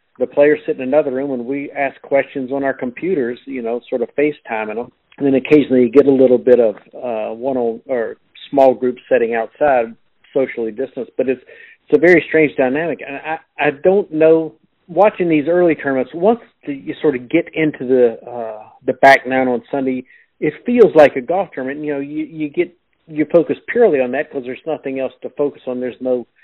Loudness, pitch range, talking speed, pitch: -16 LUFS, 125-155 Hz, 215 wpm, 140 Hz